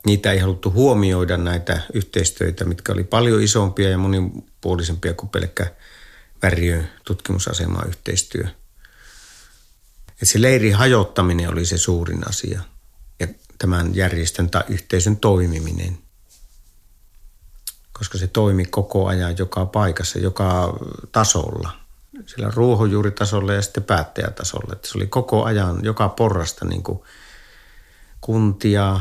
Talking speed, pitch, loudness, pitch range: 115 wpm, 95 Hz, -20 LUFS, 90-105 Hz